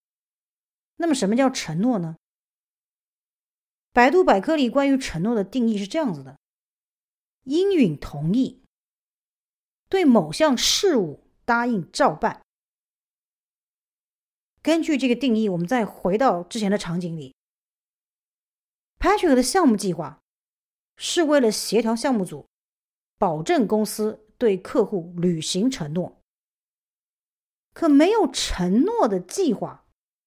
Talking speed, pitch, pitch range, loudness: 185 characters per minute, 235 Hz, 190-290 Hz, -22 LUFS